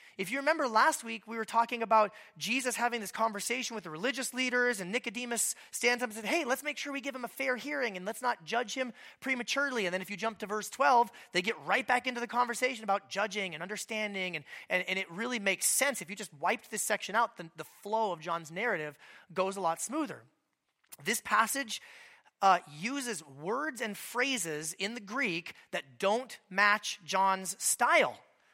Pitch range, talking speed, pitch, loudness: 190-250 Hz, 205 wpm, 225 Hz, -32 LUFS